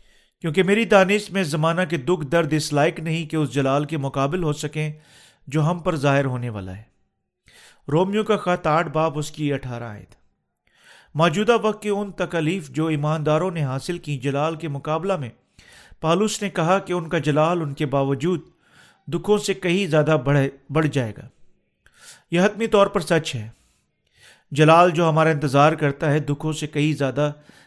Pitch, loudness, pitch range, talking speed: 155 Hz, -21 LUFS, 145-180 Hz, 180 wpm